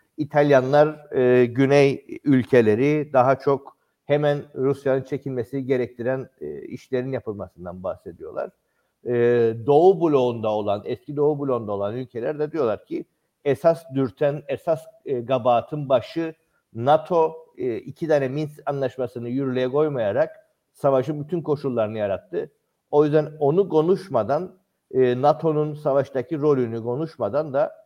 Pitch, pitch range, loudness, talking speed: 140 Hz, 125-155 Hz, -22 LUFS, 115 wpm